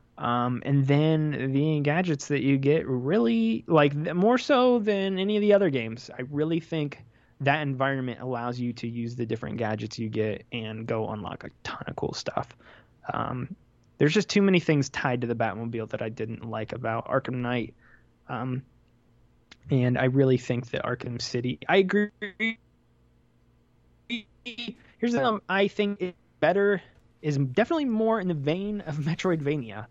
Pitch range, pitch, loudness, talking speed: 120-190 Hz, 140 Hz, -27 LUFS, 165 wpm